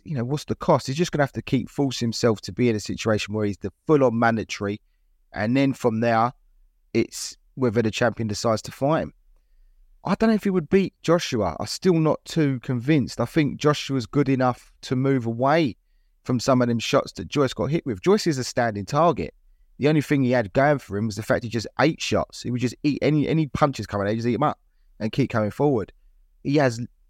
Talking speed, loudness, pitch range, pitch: 235 wpm, -23 LUFS, 115-145 Hz, 125 Hz